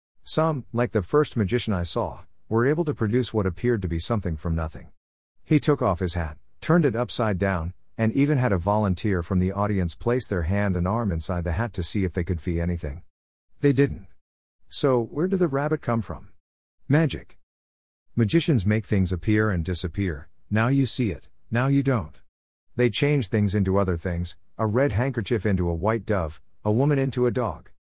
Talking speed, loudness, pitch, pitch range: 195 wpm, -25 LUFS, 100 Hz, 85-120 Hz